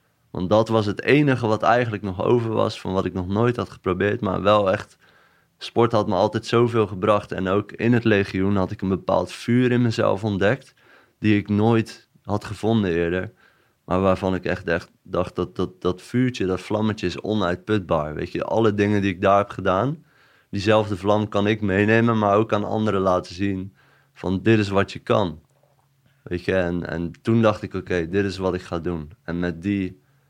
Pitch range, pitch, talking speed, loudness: 95-110 Hz, 105 Hz, 205 wpm, -22 LUFS